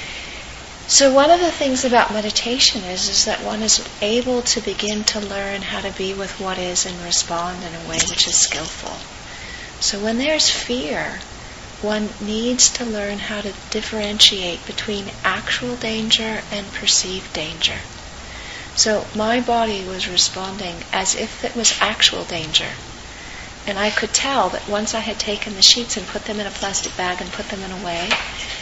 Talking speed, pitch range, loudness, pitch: 175 wpm, 190-225 Hz, -18 LUFS, 210 Hz